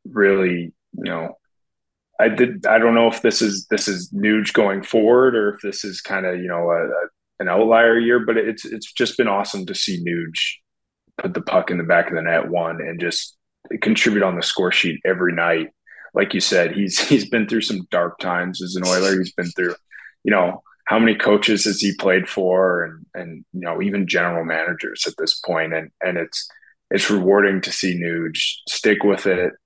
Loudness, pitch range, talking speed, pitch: -19 LUFS, 85-105 Hz, 210 wpm, 95 Hz